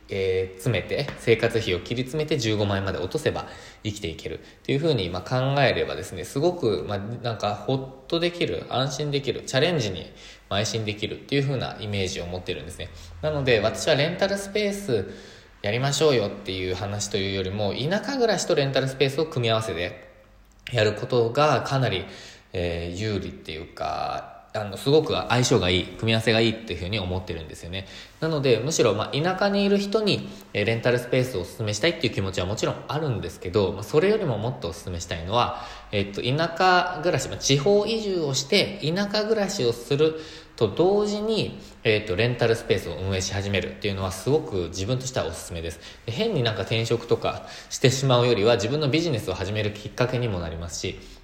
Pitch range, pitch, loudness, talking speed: 95-145 Hz, 115 Hz, -25 LUFS, 400 characters per minute